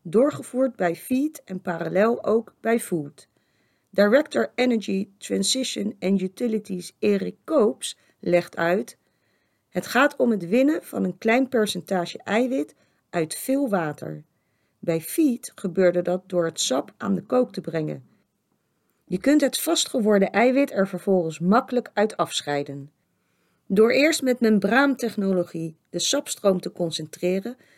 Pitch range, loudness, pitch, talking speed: 175-245 Hz, -23 LUFS, 200 Hz, 130 wpm